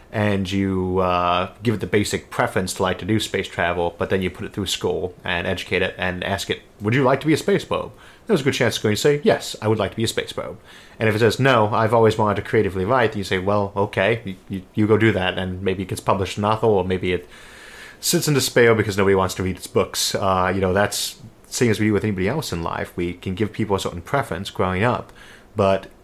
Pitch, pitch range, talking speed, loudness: 100 Hz, 95-110 Hz, 270 wpm, -21 LUFS